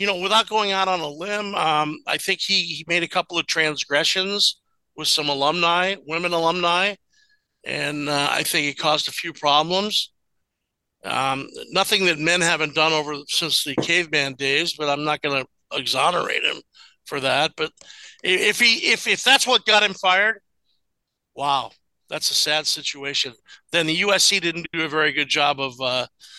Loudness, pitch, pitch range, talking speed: -20 LUFS, 165 Hz, 150-195 Hz, 175 wpm